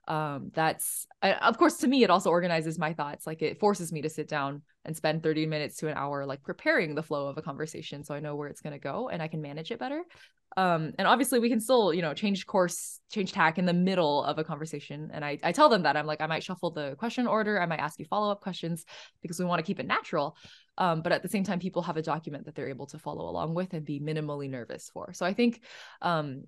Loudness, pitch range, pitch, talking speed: -29 LUFS, 150-190 Hz, 160 Hz, 265 wpm